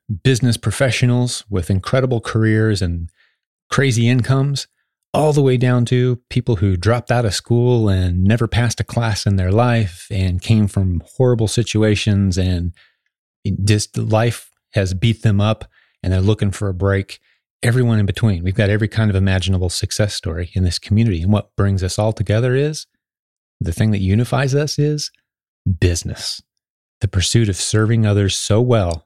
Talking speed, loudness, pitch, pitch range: 165 wpm, -17 LUFS, 110 Hz, 95-120 Hz